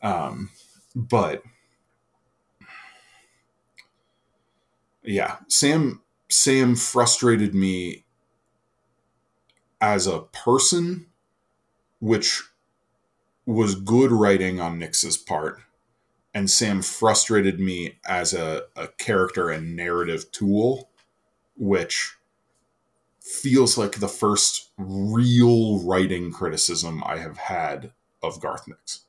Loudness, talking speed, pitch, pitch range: -22 LUFS, 85 wpm, 105 Hz, 95-120 Hz